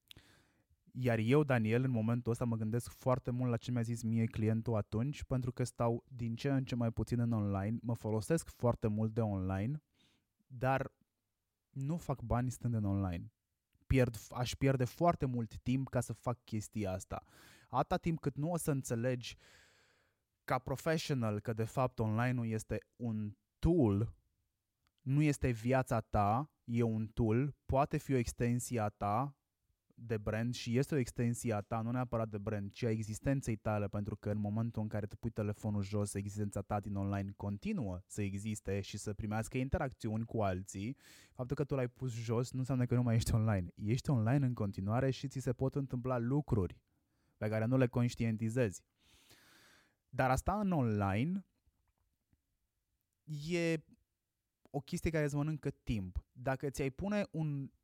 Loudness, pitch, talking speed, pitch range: -37 LUFS, 115 Hz, 170 wpm, 105-130 Hz